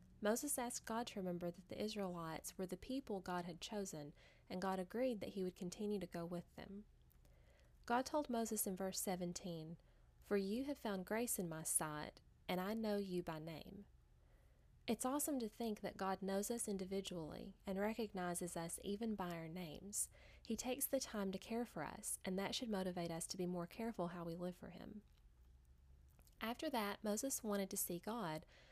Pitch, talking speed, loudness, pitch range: 195 Hz, 190 wpm, -45 LUFS, 175-220 Hz